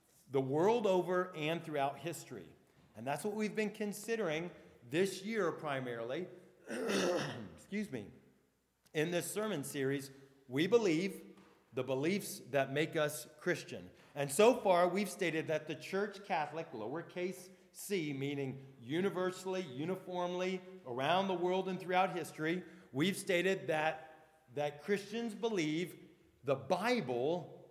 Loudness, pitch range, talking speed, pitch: -37 LUFS, 150-185 Hz, 125 wpm, 175 Hz